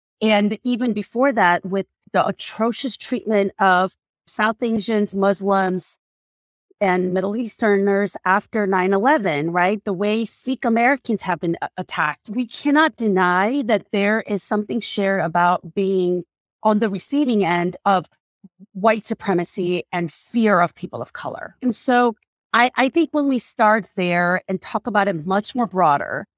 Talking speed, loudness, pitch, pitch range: 150 wpm, -20 LUFS, 205 Hz, 185-230 Hz